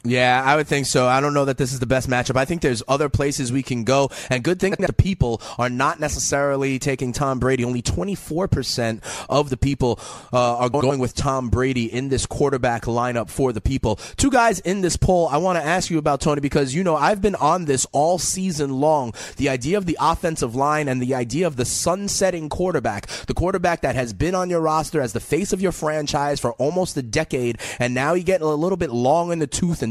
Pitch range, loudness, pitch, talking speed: 125-165 Hz, -21 LUFS, 140 Hz, 235 wpm